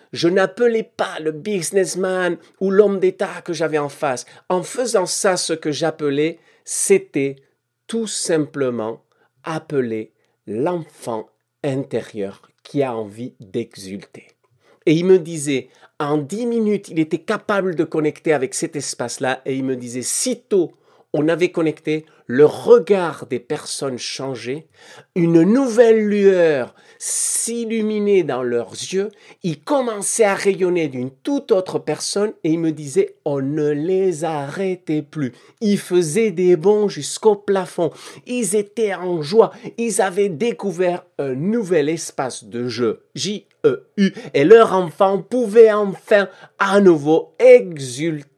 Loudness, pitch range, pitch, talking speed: -19 LUFS, 150-205 Hz, 175 Hz, 135 wpm